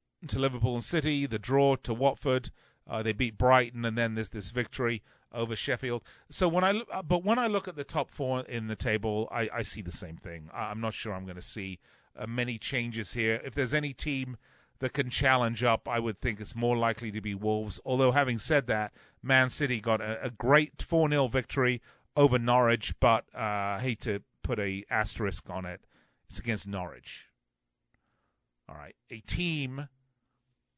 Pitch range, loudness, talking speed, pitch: 110-130 Hz, -30 LUFS, 195 wpm, 120 Hz